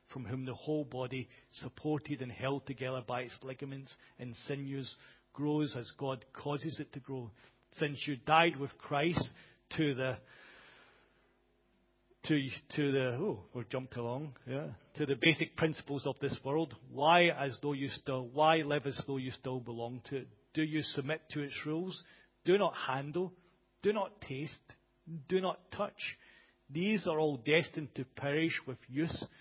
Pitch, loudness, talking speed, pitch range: 140 Hz, -36 LUFS, 160 wpm, 130-155 Hz